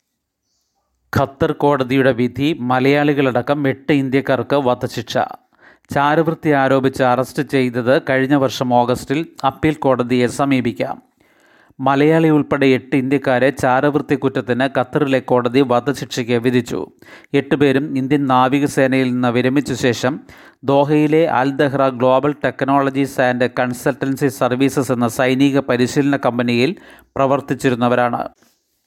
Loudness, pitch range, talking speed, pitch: -17 LUFS, 125-145 Hz, 95 wpm, 135 Hz